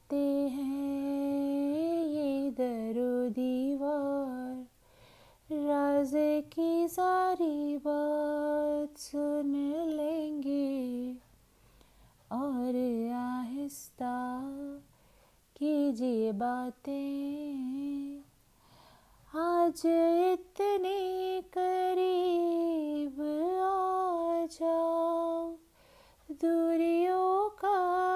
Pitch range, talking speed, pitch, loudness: 280-335 Hz, 45 wpm, 295 Hz, -32 LUFS